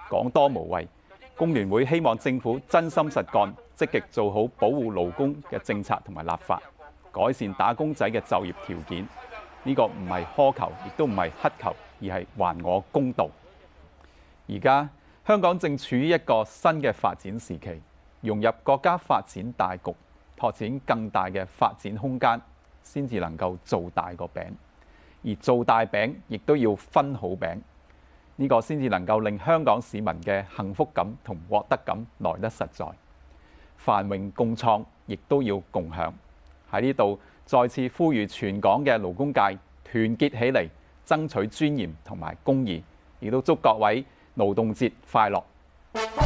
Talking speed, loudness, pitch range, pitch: 230 characters per minute, -26 LUFS, 85-130 Hz, 105 Hz